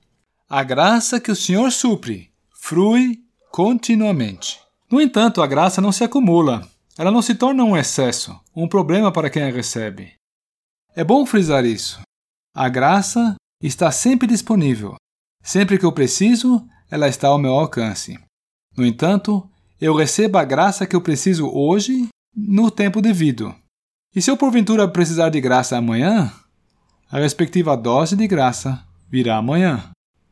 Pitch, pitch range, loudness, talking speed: 175 Hz, 130-215 Hz, -17 LUFS, 145 wpm